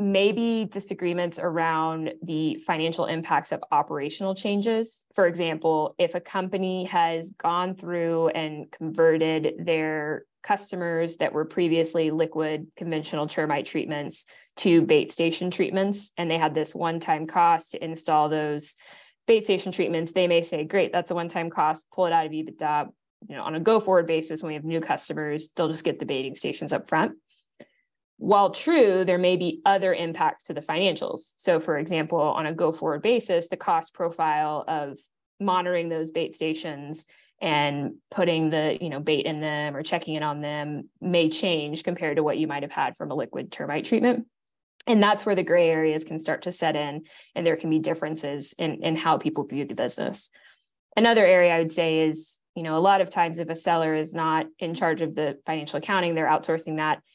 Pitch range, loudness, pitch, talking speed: 155-180 Hz, -25 LUFS, 165 Hz, 185 wpm